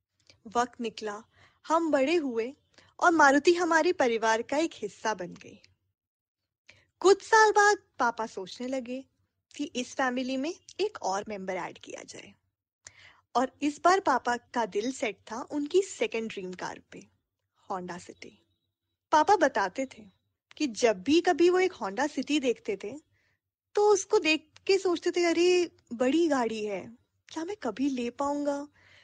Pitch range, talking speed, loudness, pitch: 210-330 Hz, 150 wpm, -28 LUFS, 260 Hz